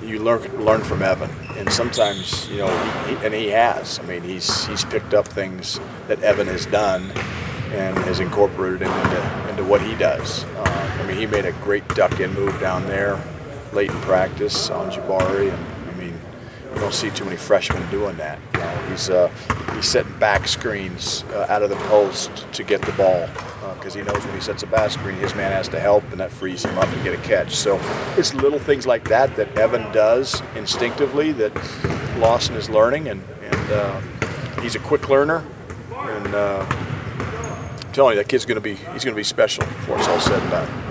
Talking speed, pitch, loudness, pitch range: 210 wpm, 105 Hz, -21 LUFS, 95-125 Hz